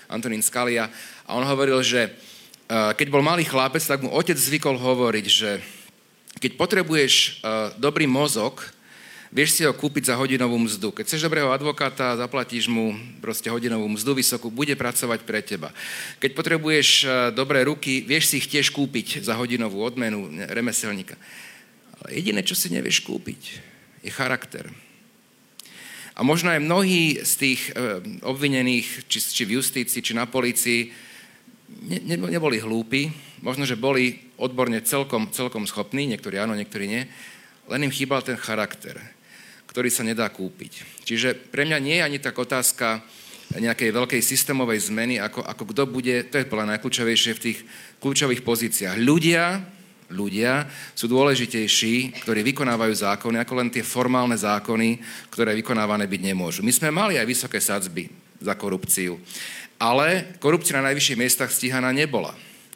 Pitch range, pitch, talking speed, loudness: 115-140 Hz, 125 Hz, 145 wpm, -22 LUFS